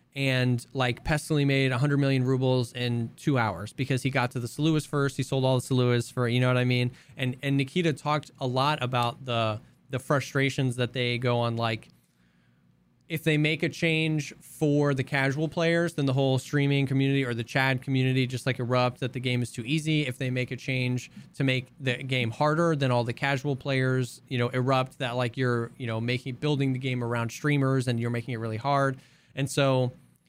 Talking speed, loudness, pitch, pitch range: 210 wpm, -27 LUFS, 130 Hz, 125-140 Hz